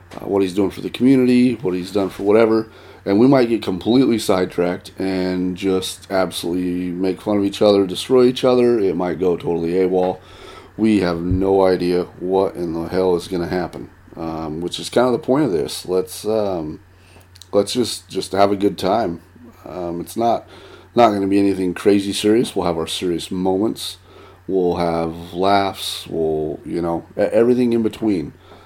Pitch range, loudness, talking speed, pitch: 90-100 Hz, -19 LUFS, 185 wpm, 95 Hz